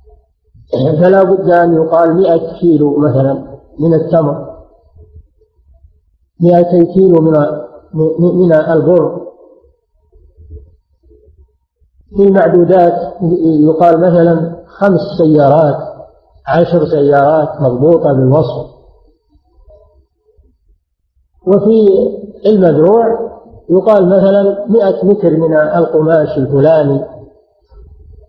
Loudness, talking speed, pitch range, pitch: -10 LUFS, 70 wpm, 130-175 Hz, 160 Hz